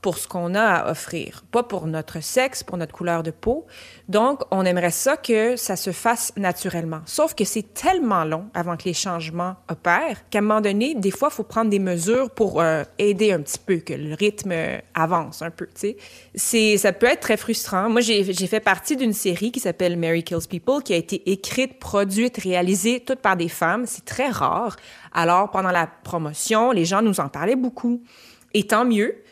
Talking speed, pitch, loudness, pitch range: 210 wpm, 195 Hz, -22 LUFS, 175-225 Hz